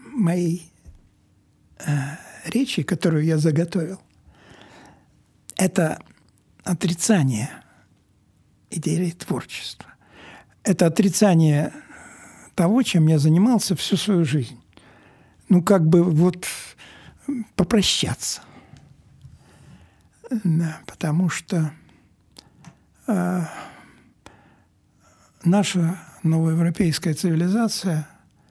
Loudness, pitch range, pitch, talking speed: -21 LUFS, 155-195 Hz, 170 Hz, 65 wpm